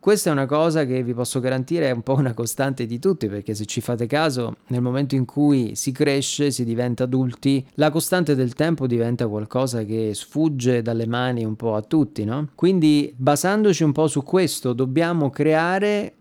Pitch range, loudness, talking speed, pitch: 120-155 Hz, -21 LUFS, 195 wpm, 135 Hz